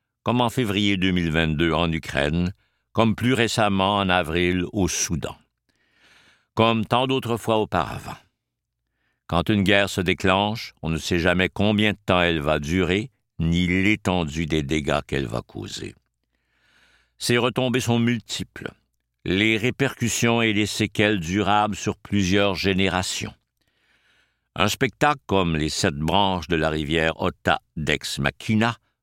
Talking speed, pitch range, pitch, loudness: 135 wpm, 85-110 Hz, 100 Hz, -22 LUFS